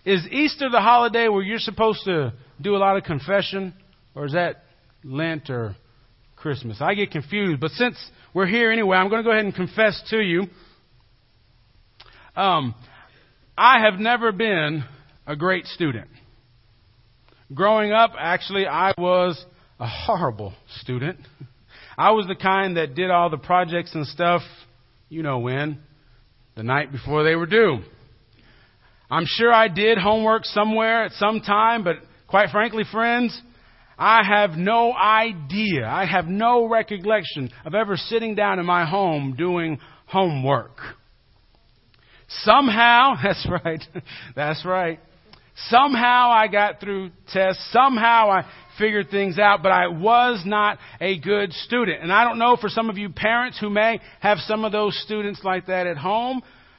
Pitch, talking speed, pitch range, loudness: 185 Hz, 150 wpm, 145-215 Hz, -20 LUFS